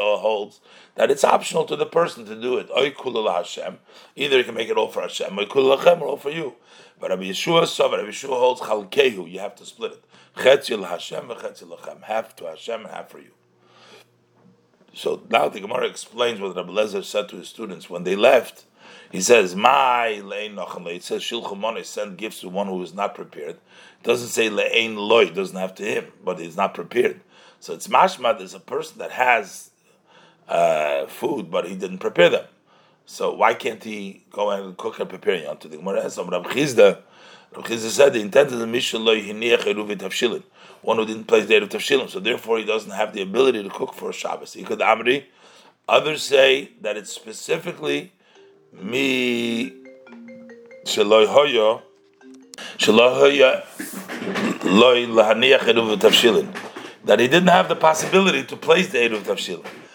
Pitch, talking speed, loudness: 370 Hz, 155 wpm, -20 LUFS